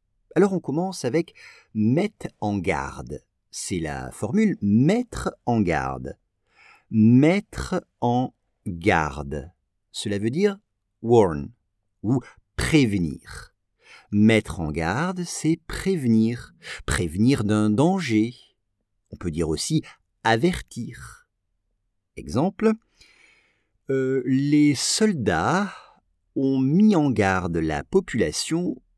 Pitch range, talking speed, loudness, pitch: 100-155 Hz, 95 wpm, -23 LUFS, 110 Hz